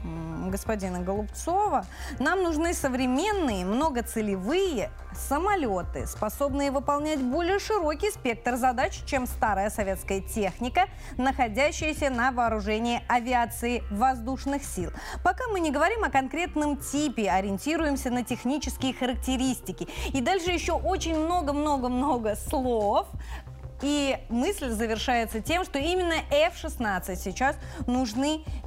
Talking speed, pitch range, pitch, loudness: 105 wpm, 225-310 Hz, 265 Hz, -27 LUFS